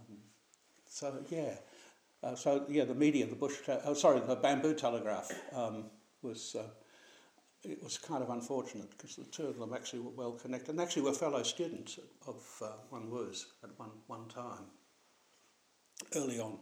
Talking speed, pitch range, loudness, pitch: 170 wpm, 115-140 Hz, -37 LUFS, 125 Hz